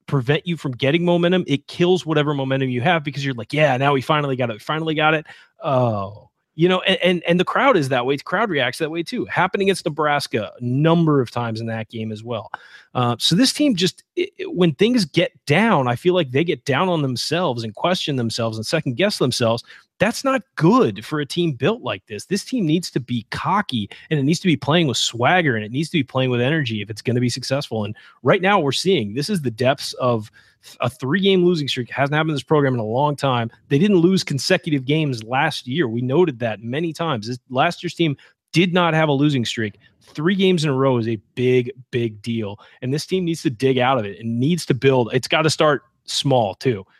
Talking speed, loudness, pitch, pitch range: 245 wpm, -20 LUFS, 145 Hz, 125-170 Hz